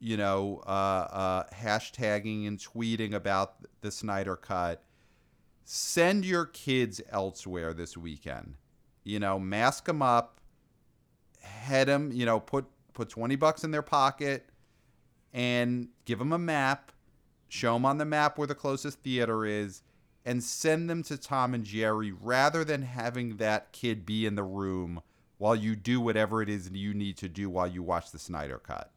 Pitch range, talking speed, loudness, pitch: 100-135 Hz, 165 wpm, -31 LUFS, 110 Hz